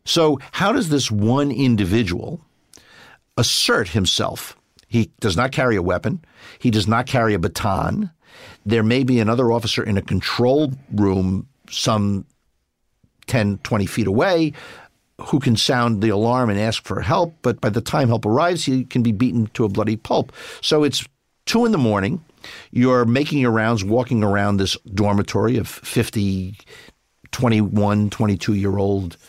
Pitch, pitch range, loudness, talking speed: 115 Hz, 105-130 Hz, -19 LUFS, 160 wpm